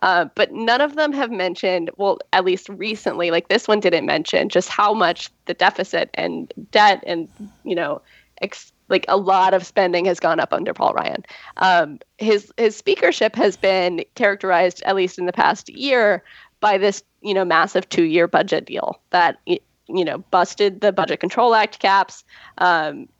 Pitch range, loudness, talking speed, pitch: 185-215 Hz, -19 LUFS, 180 wpm, 195 Hz